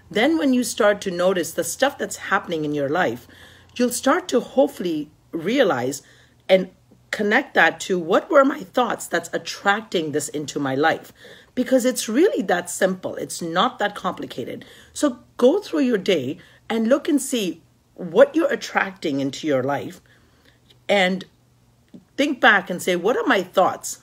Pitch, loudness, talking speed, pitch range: 210 Hz, -21 LUFS, 160 wpm, 175-265 Hz